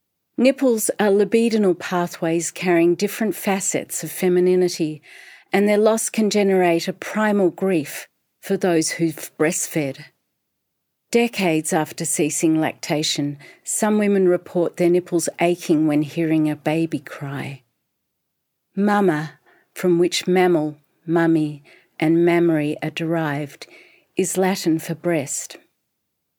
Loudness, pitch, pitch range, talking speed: -20 LUFS, 170 Hz, 155-190 Hz, 110 wpm